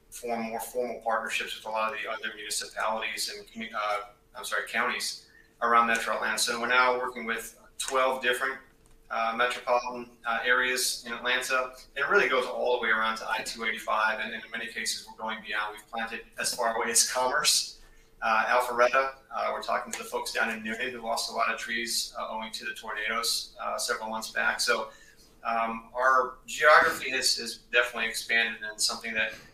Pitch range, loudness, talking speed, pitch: 110-125 Hz, -28 LUFS, 190 wpm, 115 Hz